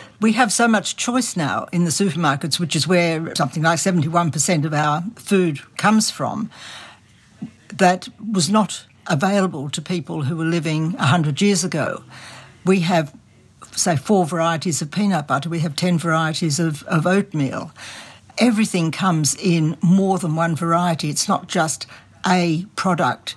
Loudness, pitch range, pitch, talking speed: -19 LUFS, 155-190 Hz, 170 Hz, 150 wpm